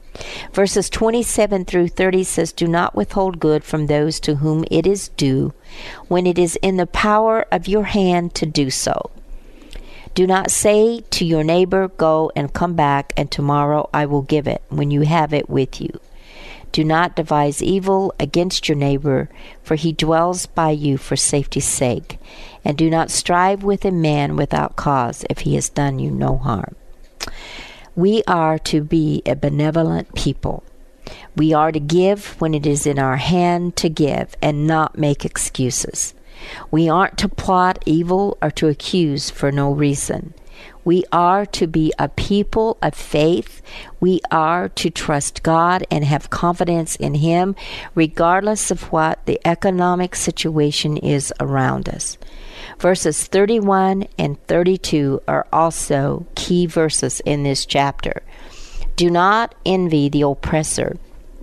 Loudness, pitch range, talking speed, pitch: -18 LUFS, 145-180 Hz, 155 wpm, 160 Hz